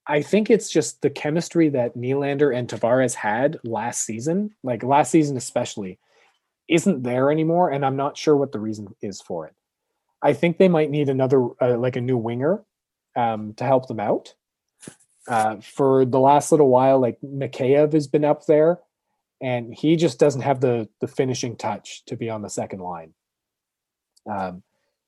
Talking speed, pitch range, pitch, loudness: 175 wpm, 120-150 Hz, 135 Hz, -21 LUFS